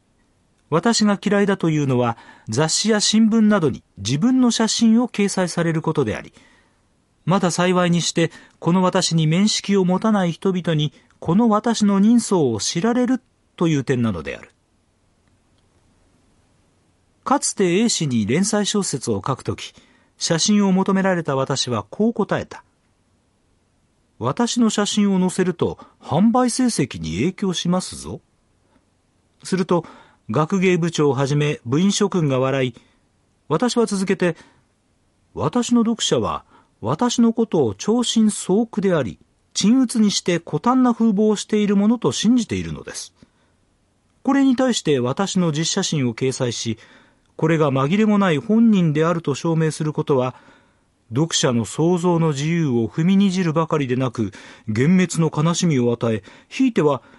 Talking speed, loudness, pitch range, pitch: 275 characters per minute, -19 LUFS, 135-210 Hz, 175 Hz